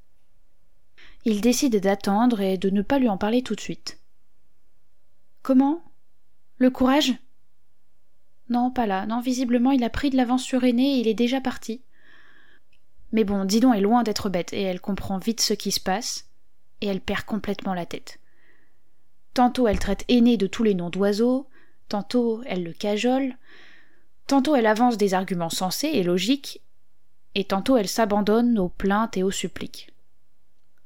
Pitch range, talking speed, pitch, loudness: 200-255 Hz, 165 wpm, 230 Hz, -23 LUFS